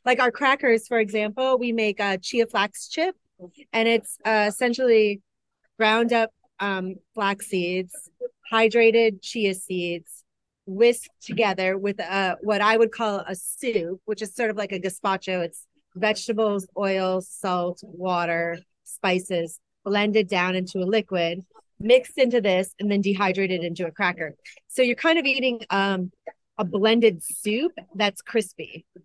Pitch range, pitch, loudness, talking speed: 185-230 Hz, 205 Hz, -23 LUFS, 145 wpm